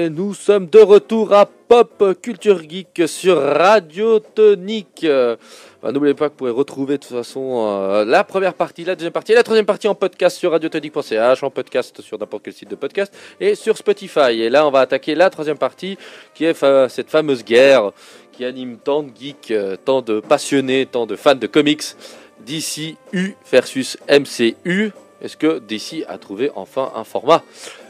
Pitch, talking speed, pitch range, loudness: 160 Hz, 175 wpm, 135-200 Hz, -16 LUFS